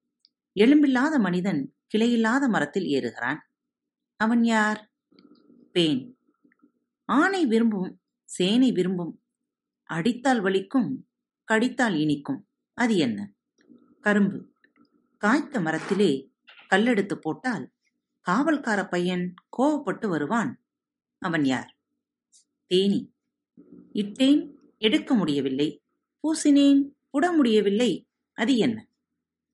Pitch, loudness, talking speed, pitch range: 245 Hz, -24 LUFS, 75 wpm, 200-275 Hz